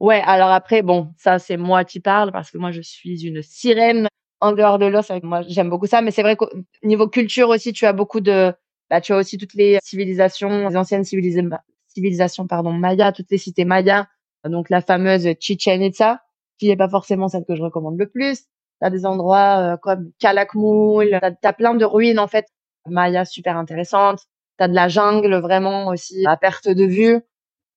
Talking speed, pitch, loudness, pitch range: 205 wpm, 195 Hz, -17 LUFS, 180-210 Hz